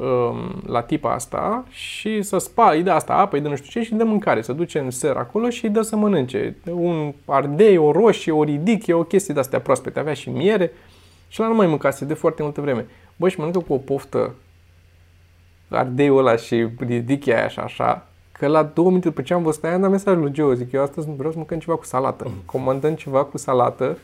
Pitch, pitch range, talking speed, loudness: 150 Hz, 130-175 Hz, 230 wpm, -20 LUFS